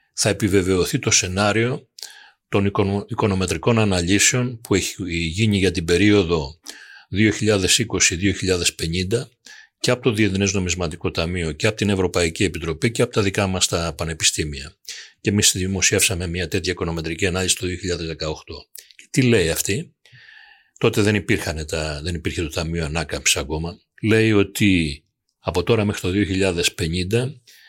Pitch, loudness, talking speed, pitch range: 95 Hz, -20 LUFS, 135 wpm, 85-105 Hz